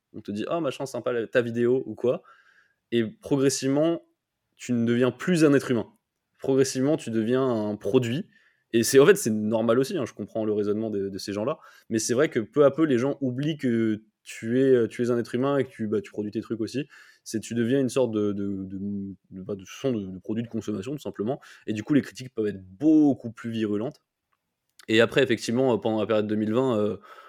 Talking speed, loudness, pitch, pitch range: 200 wpm, -25 LUFS, 115 Hz, 105-130 Hz